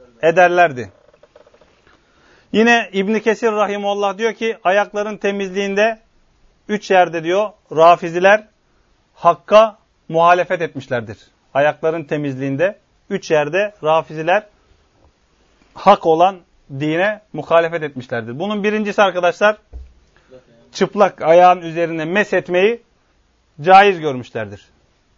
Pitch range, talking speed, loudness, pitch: 150-205 Hz, 85 wpm, -16 LUFS, 180 Hz